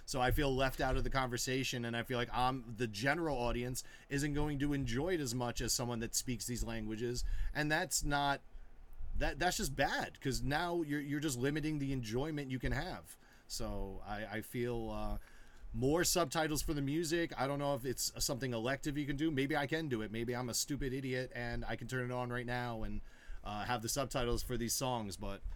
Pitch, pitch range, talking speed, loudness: 125 Hz, 120-145 Hz, 220 wpm, -37 LUFS